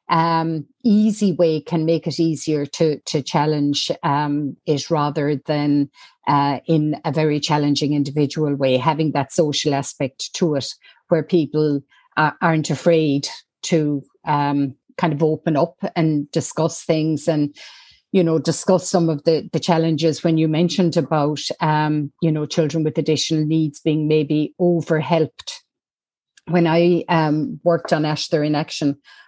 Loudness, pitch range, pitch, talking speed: -19 LUFS, 150-165 Hz, 155 Hz, 150 wpm